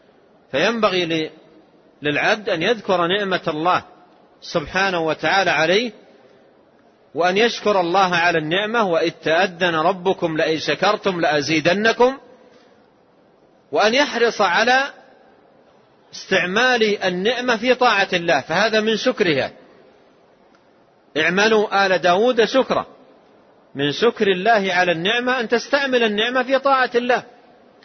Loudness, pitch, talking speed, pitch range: -18 LUFS, 205 Hz, 100 wpm, 175-240 Hz